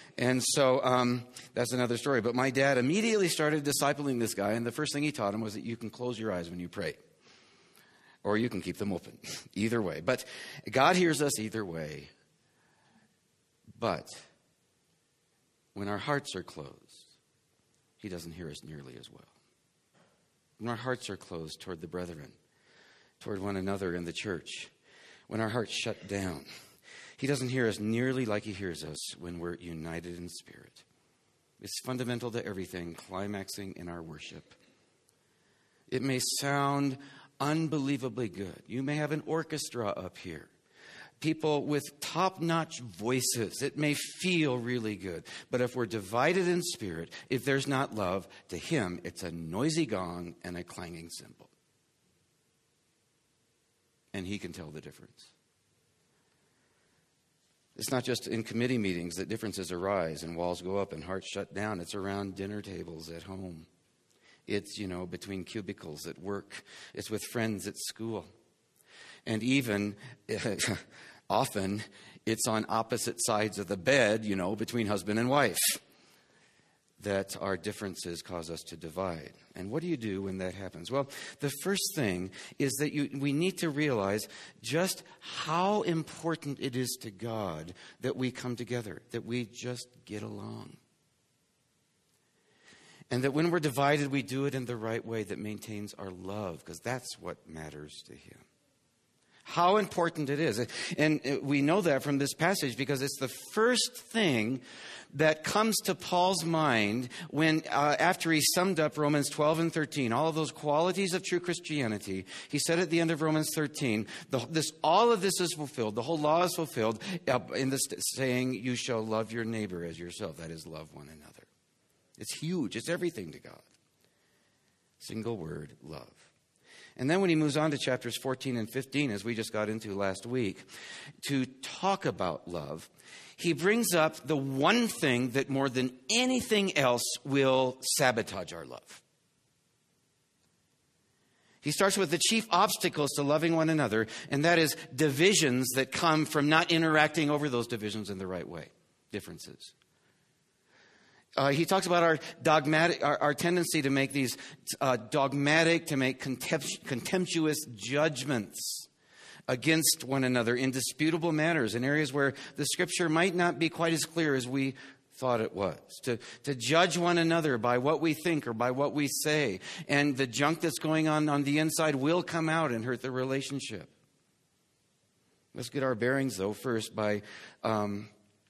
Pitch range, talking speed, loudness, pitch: 105-155 Hz, 165 wpm, -31 LUFS, 130 Hz